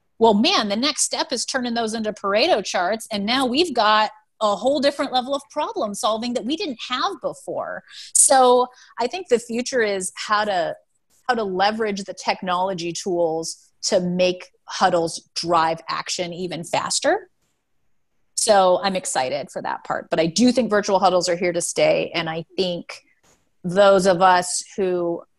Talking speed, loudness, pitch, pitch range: 170 wpm, -20 LUFS, 205 Hz, 180-250 Hz